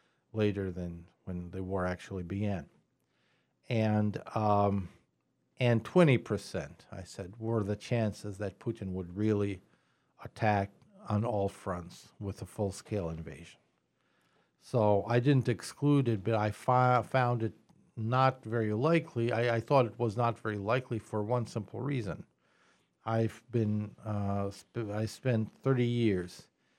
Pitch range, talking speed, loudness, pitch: 100-120 Hz, 140 wpm, -32 LUFS, 110 Hz